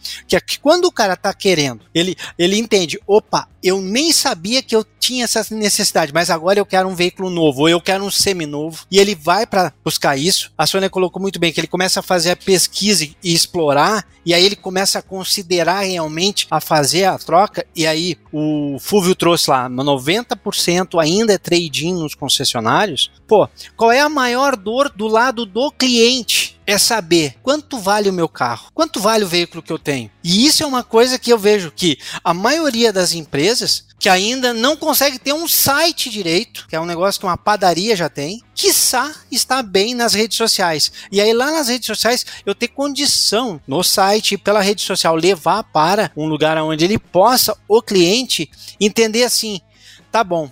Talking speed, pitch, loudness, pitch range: 195 wpm, 195 Hz, -15 LUFS, 170-230 Hz